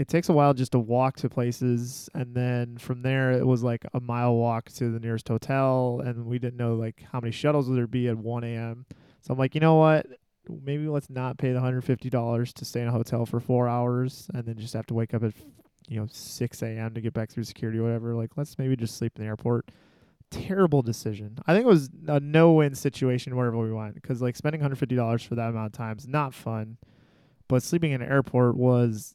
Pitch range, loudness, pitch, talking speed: 115-135 Hz, -26 LUFS, 125 Hz, 235 wpm